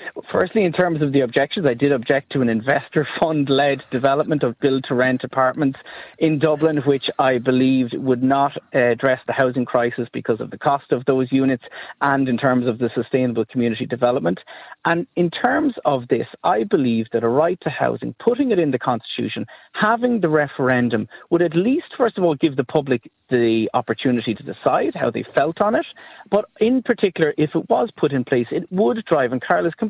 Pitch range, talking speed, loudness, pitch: 125-170 Hz, 190 wpm, -20 LUFS, 140 Hz